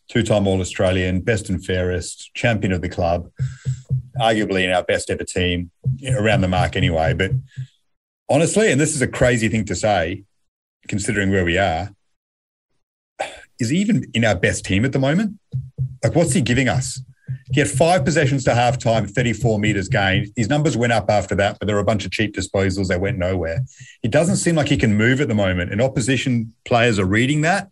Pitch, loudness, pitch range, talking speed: 115 Hz, -19 LUFS, 100-130 Hz, 205 wpm